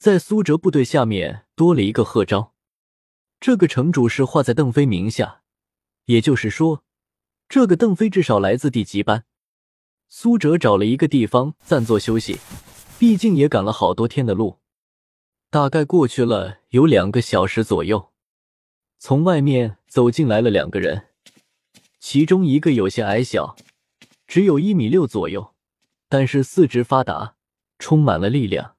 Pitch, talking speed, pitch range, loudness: 130 Hz, 225 characters per minute, 110-155 Hz, -18 LUFS